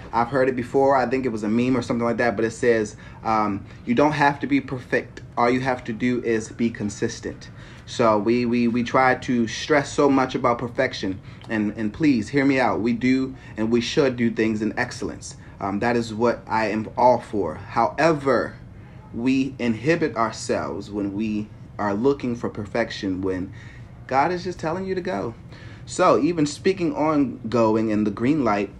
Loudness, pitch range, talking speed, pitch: -22 LUFS, 110-130 Hz, 195 wpm, 120 Hz